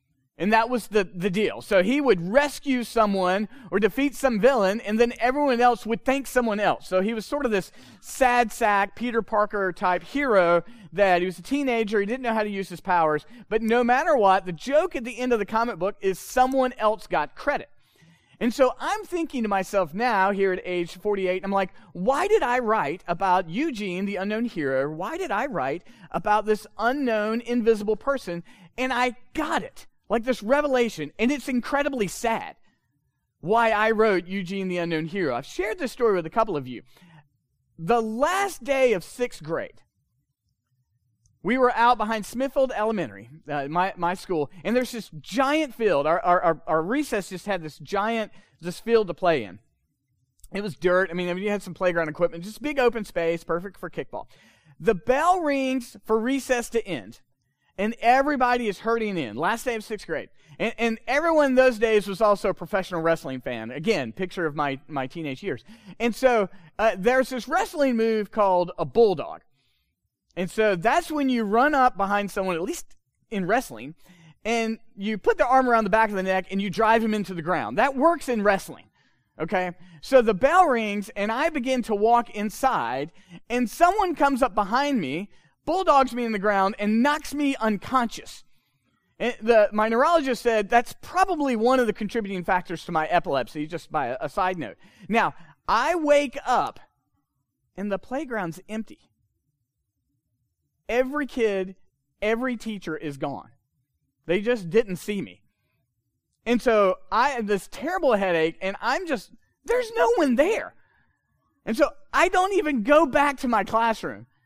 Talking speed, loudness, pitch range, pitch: 180 wpm, -24 LUFS, 180-245 Hz, 215 Hz